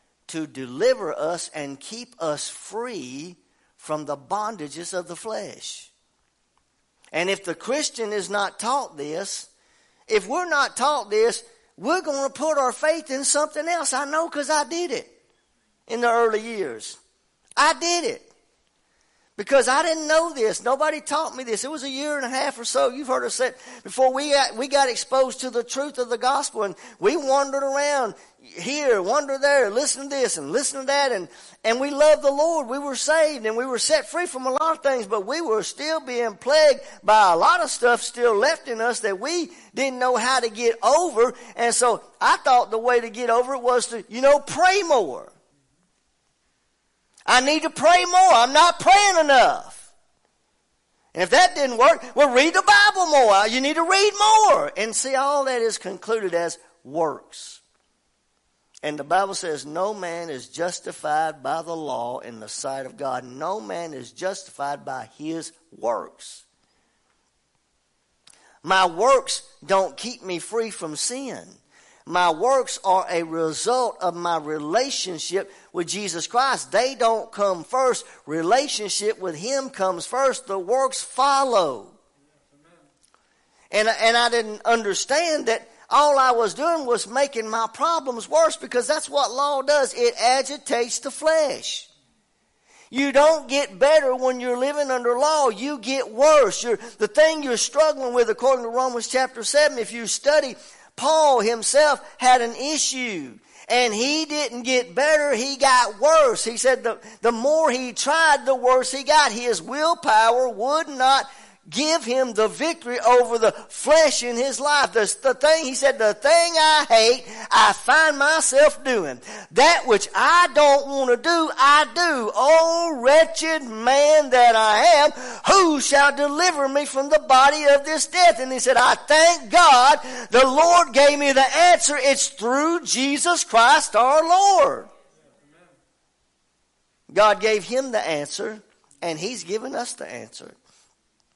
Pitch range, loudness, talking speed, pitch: 225-300 Hz, -20 LUFS, 170 wpm, 260 Hz